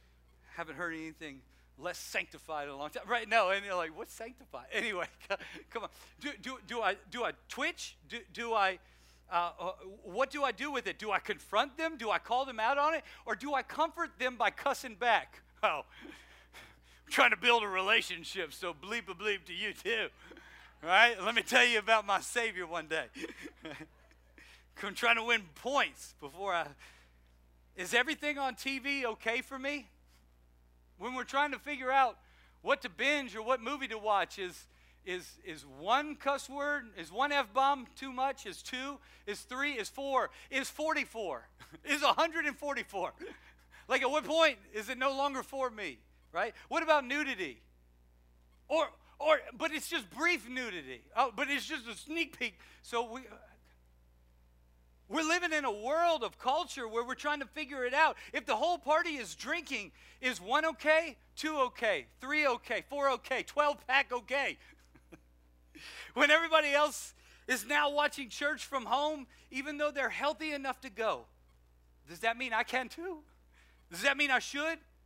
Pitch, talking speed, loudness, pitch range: 255 Hz, 175 wpm, -33 LUFS, 185-290 Hz